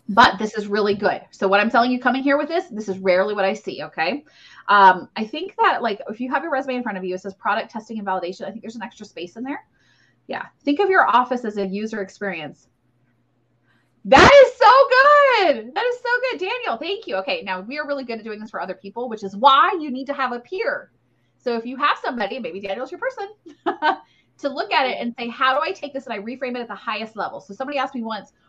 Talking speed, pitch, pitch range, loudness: 260 wpm, 240 Hz, 200-285 Hz, -19 LUFS